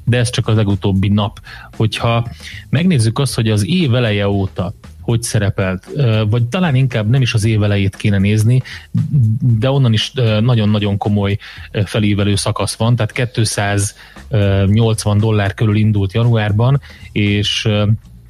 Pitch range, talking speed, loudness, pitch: 100-120 Hz, 135 wpm, -15 LUFS, 110 Hz